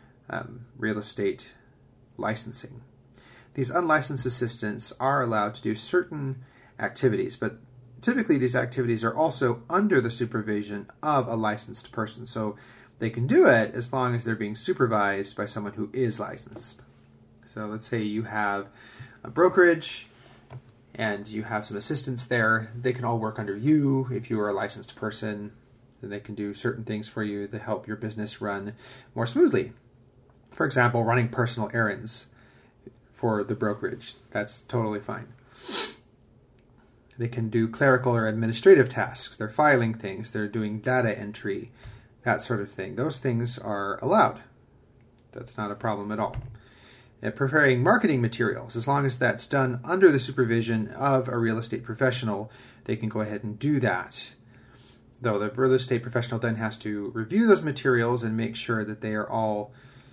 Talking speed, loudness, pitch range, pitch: 165 wpm, -26 LUFS, 110-125 Hz, 120 Hz